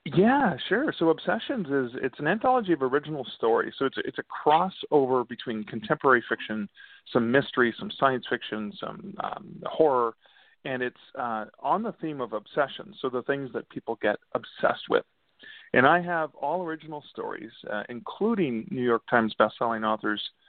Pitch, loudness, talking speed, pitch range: 135 Hz, -27 LUFS, 165 wpm, 120-165 Hz